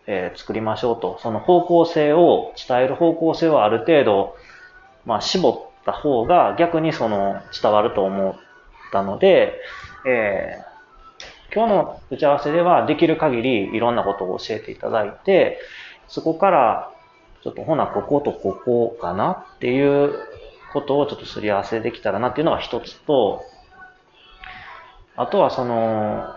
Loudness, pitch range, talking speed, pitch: -20 LUFS, 115-175 Hz, 295 characters per minute, 145 Hz